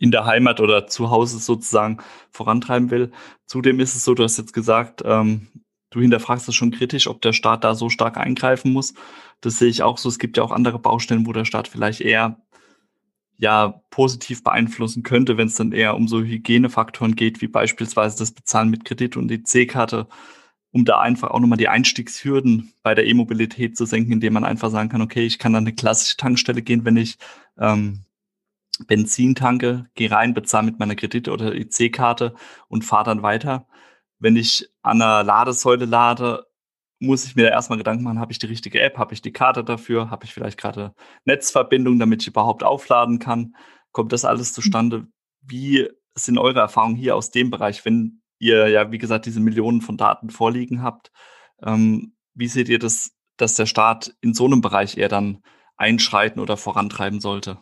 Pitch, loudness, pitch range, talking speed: 115 Hz, -19 LUFS, 110-120 Hz, 190 wpm